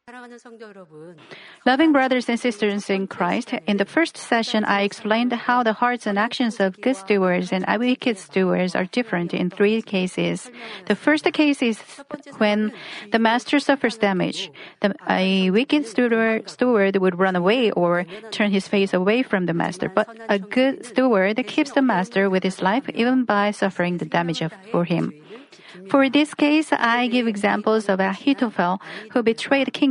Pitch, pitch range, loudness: 215 Hz, 195-245 Hz, -21 LUFS